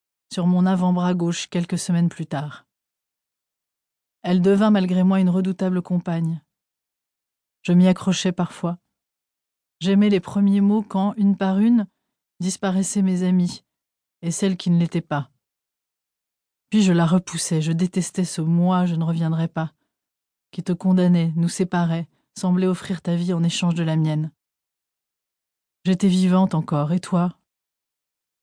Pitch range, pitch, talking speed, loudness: 170-190 Hz, 180 Hz, 140 wpm, -21 LUFS